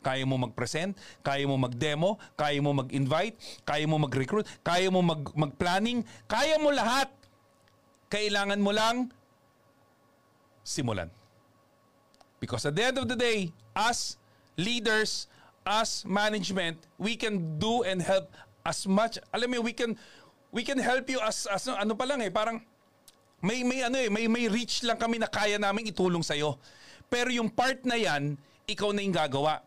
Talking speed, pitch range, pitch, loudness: 160 wpm, 155-230 Hz, 200 Hz, -29 LUFS